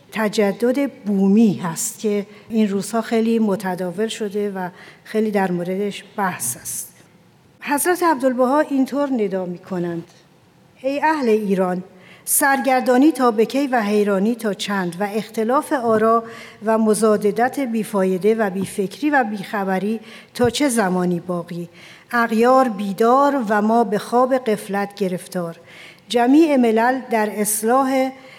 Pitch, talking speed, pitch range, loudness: 215 Hz, 120 wpm, 195-245 Hz, -19 LUFS